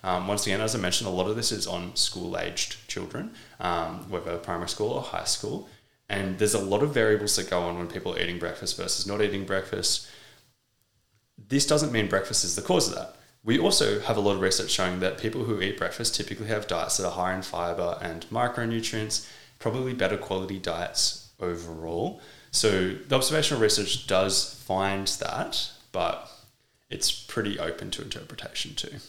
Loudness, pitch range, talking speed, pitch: -27 LUFS, 95-110 Hz, 190 wpm, 100 Hz